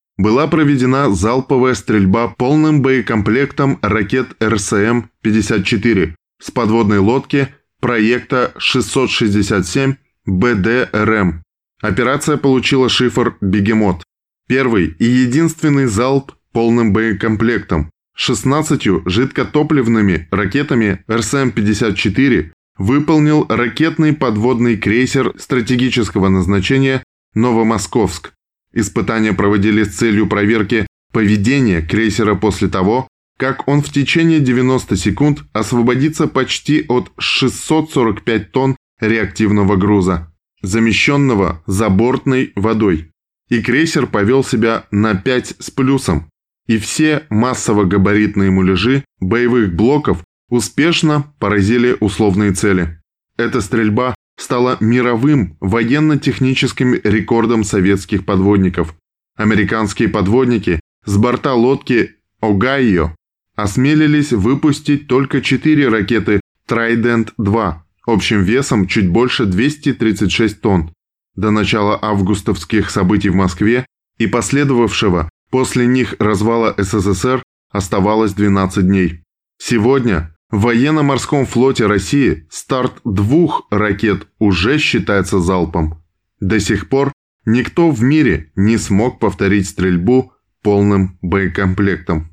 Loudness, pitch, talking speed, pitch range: -14 LUFS, 110 Hz, 95 wpm, 100-130 Hz